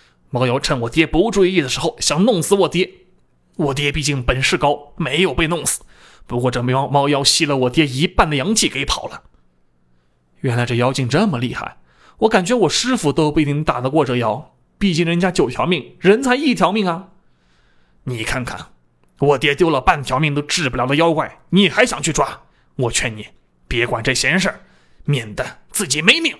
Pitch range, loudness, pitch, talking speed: 125-180 Hz, -17 LUFS, 145 Hz, 275 characters per minute